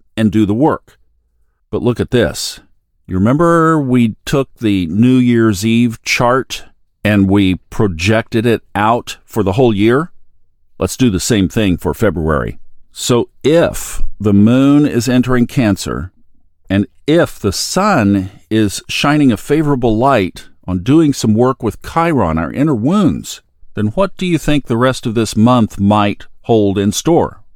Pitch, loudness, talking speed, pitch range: 110 Hz, -13 LUFS, 155 wpm, 100-125 Hz